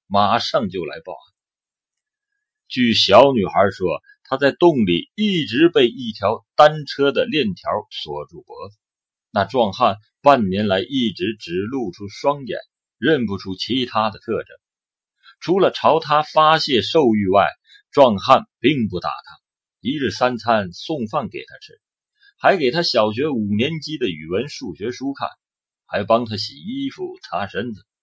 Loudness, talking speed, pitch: -19 LUFS, 210 characters per minute, 150 Hz